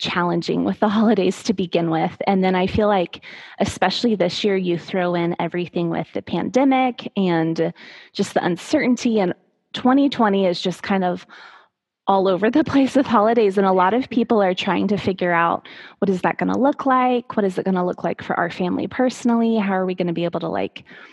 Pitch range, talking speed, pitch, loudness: 180-235 Hz, 215 wpm, 195 Hz, -20 LUFS